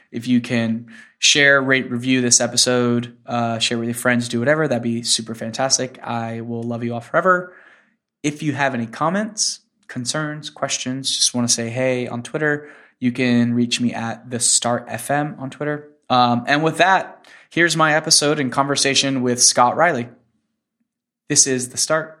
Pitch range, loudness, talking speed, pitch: 120-150 Hz, -18 LUFS, 175 wpm, 130 Hz